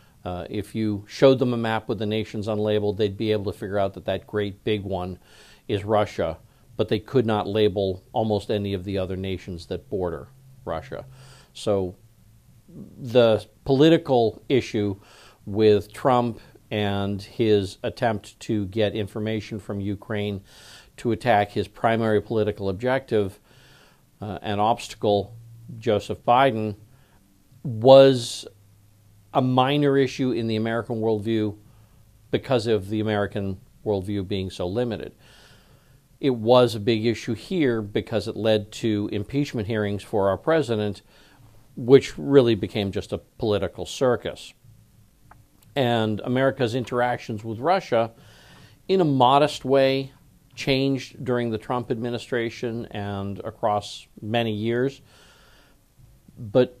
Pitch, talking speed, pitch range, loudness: 110 Hz, 125 wpm, 105-125 Hz, -24 LUFS